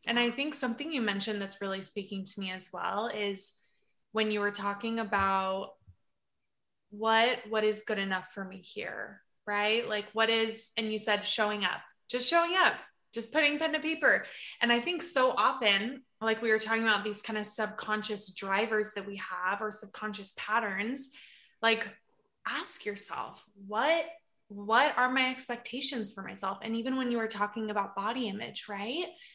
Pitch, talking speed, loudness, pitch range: 215 Hz, 175 wpm, -31 LUFS, 200-240 Hz